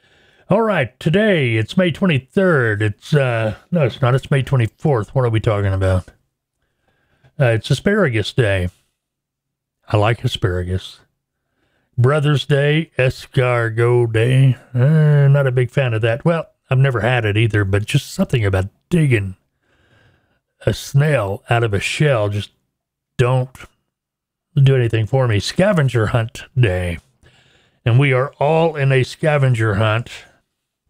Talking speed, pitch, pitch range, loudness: 140 wpm, 125 Hz, 110-140 Hz, -17 LUFS